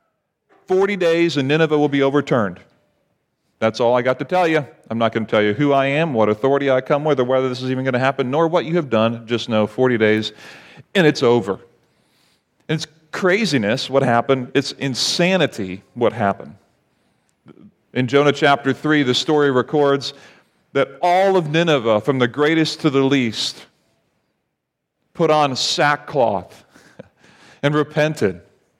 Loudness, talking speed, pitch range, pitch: -18 LUFS, 165 wpm, 125-155 Hz, 140 Hz